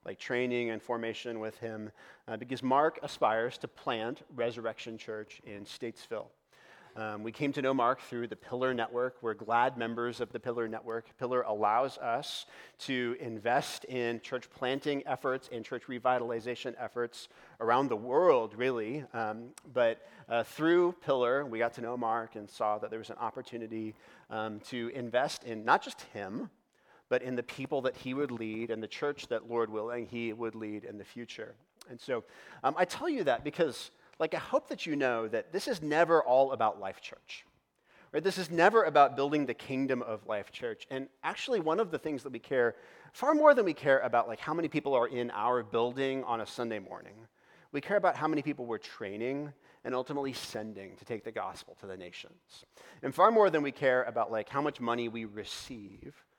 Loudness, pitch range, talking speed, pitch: -32 LUFS, 115-135 Hz, 195 wpm, 120 Hz